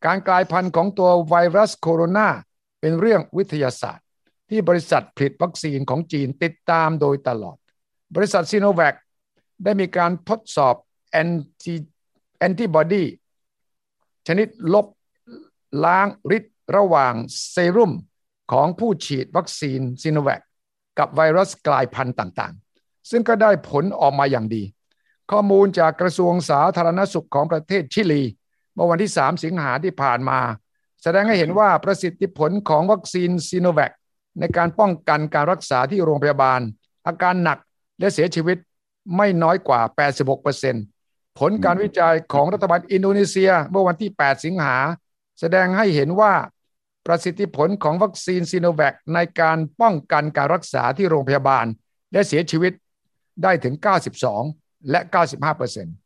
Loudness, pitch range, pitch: -19 LUFS, 145-190 Hz, 170 Hz